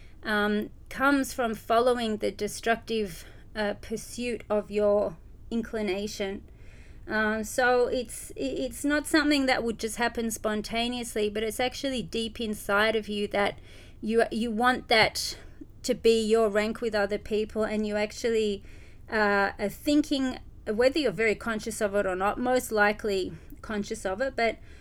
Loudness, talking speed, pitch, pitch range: -28 LUFS, 150 wpm, 220 Hz, 210-235 Hz